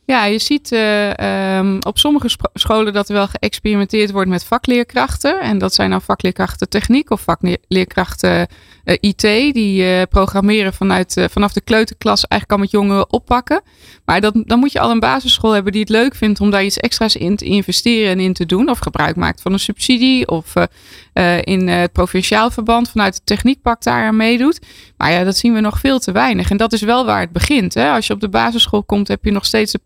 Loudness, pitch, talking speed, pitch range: -14 LUFS, 205 Hz, 225 wpm, 190-230 Hz